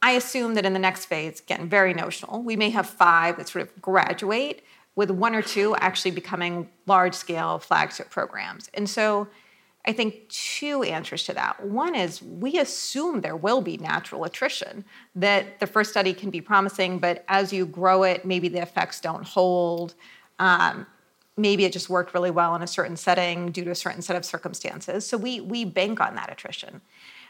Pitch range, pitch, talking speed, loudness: 180-210 Hz, 190 Hz, 190 wpm, -24 LUFS